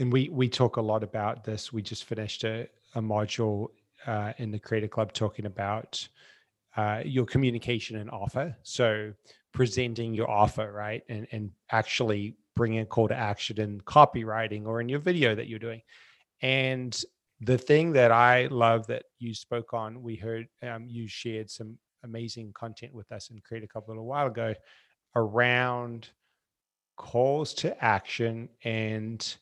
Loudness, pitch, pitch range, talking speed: -28 LUFS, 115 Hz, 110-120 Hz, 165 wpm